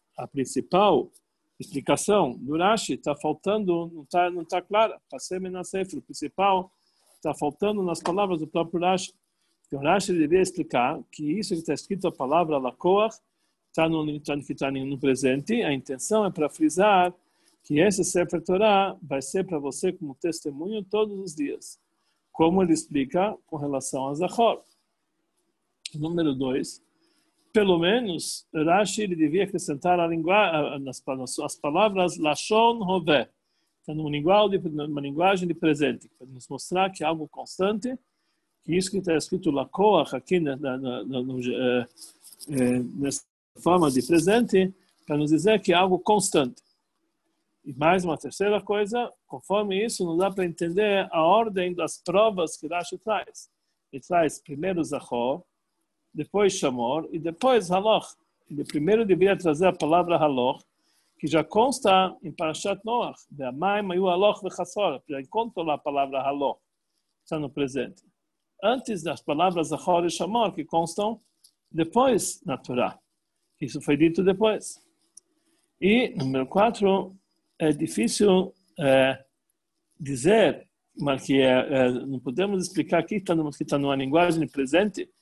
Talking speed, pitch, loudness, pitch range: 140 wpm, 175 Hz, -25 LUFS, 150-200 Hz